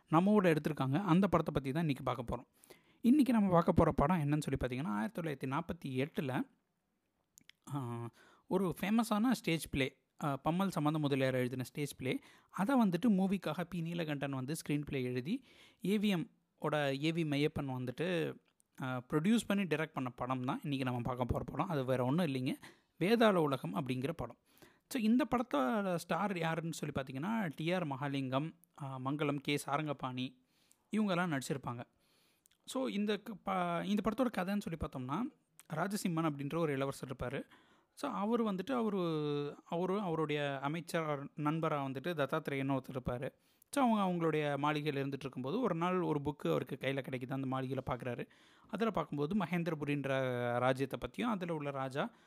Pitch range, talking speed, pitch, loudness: 135-185 Hz, 145 wpm, 155 Hz, -36 LUFS